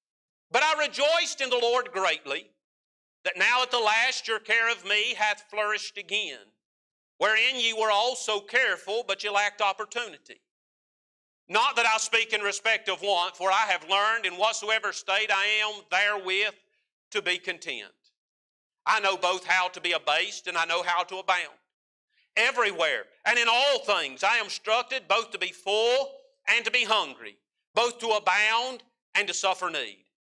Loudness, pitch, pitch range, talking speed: -25 LUFS, 210 Hz, 195-235 Hz, 170 wpm